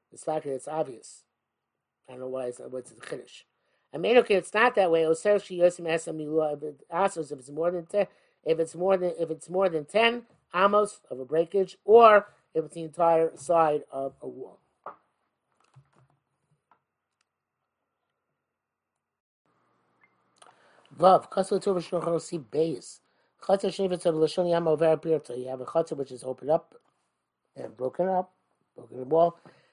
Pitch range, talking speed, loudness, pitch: 145-185 Hz, 120 wpm, -26 LUFS, 165 Hz